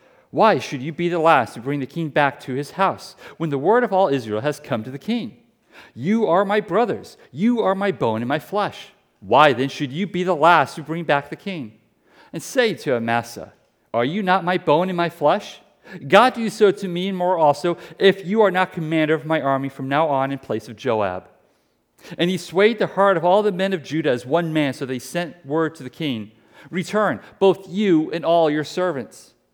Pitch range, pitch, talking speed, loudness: 145-190 Hz, 165 Hz, 225 wpm, -20 LUFS